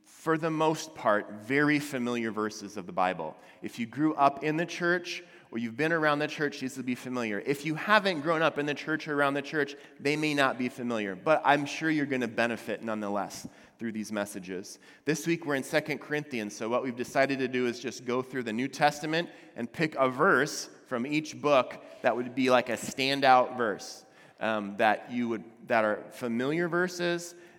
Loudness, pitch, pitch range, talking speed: -29 LUFS, 135 Hz, 115-155 Hz, 210 wpm